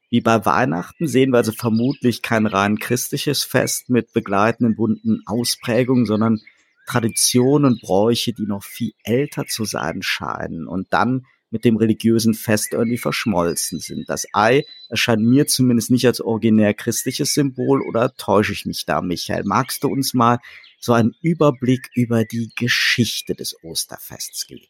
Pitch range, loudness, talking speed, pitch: 110-130 Hz, -19 LUFS, 155 wpm, 120 Hz